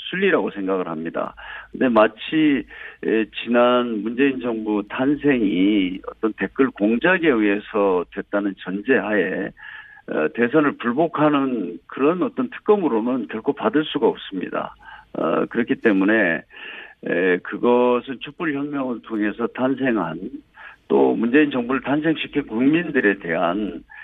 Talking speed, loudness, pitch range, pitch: 260 characters per minute, -21 LUFS, 110-150 Hz, 125 Hz